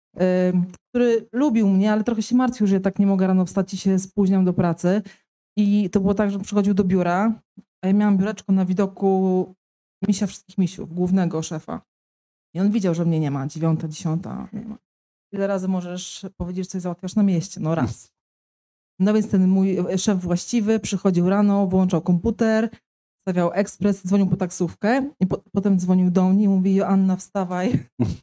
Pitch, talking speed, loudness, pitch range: 190 Hz, 185 wpm, -21 LUFS, 180-205 Hz